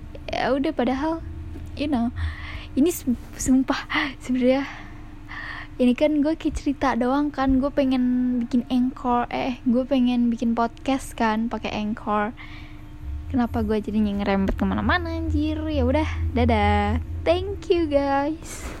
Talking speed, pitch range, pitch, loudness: 120 wpm, 200-275 Hz, 245 Hz, -23 LUFS